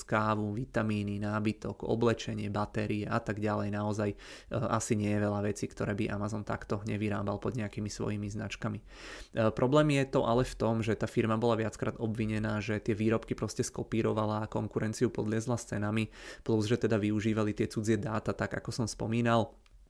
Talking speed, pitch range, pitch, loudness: 175 wpm, 105-115 Hz, 110 Hz, -32 LUFS